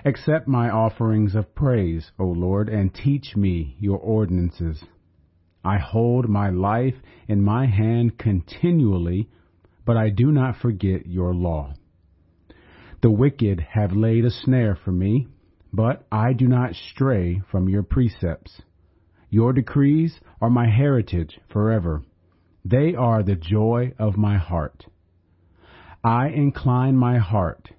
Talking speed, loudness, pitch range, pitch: 130 wpm, -21 LUFS, 90-120 Hz, 105 Hz